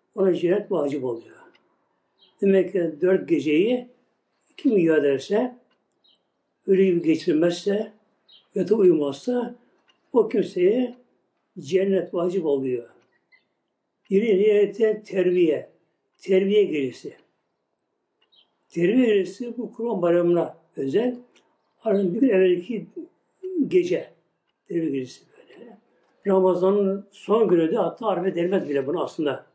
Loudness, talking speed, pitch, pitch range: -23 LUFS, 105 wpm, 195 Hz, 175-230 Hz